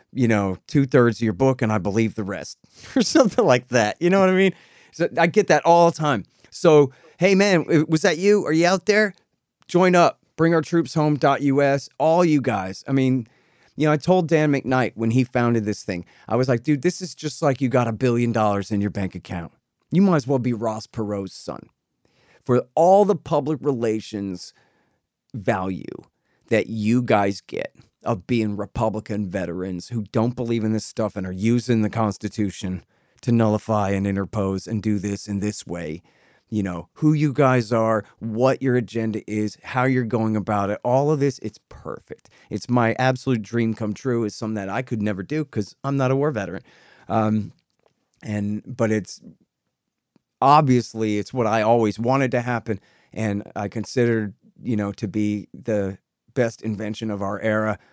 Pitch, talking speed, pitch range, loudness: 115 Hz, 195 wpm, 105-140 Hz, -21 LUFS